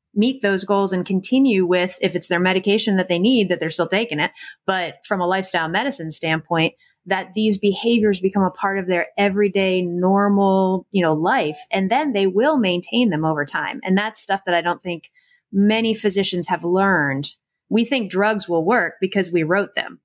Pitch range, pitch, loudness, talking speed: 175-205 Hz, 190 Hz, -19 LUFS, 195 wpm